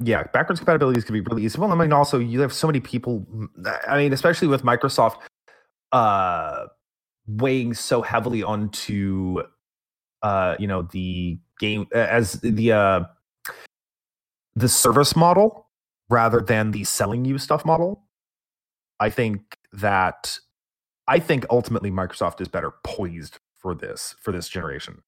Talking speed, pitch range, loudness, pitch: 140 wpm, 105-140 Hz, -22 LUFS, 115 Hz